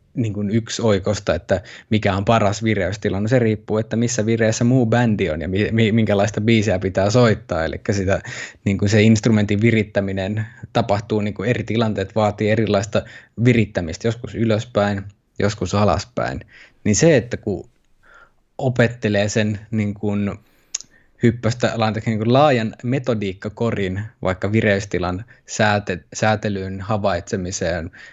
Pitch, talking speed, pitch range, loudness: 110 Hz, 125 wpm, 100-115 Hz, -20 LUFS